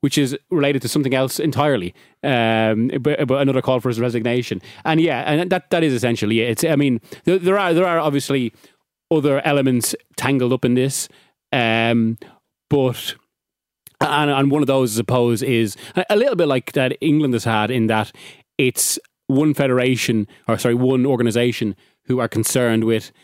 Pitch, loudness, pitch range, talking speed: 130 Hz, -19 LUFS, 115-145 Hz, 180 wpm